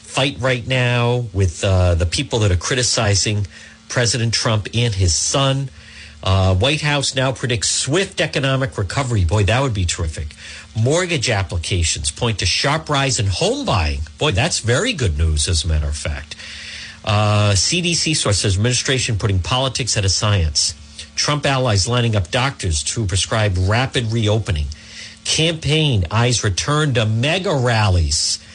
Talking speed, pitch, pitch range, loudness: 150 wpm, 110 Hz, 90-130 Hz, -18 LUFS